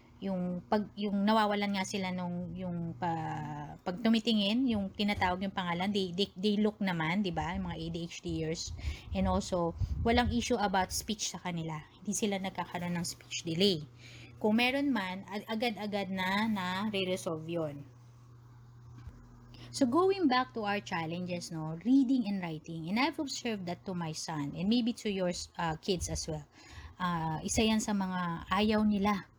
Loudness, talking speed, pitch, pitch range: -33 LUFS, 165 wpm, 185 Hz, 165-210 Hz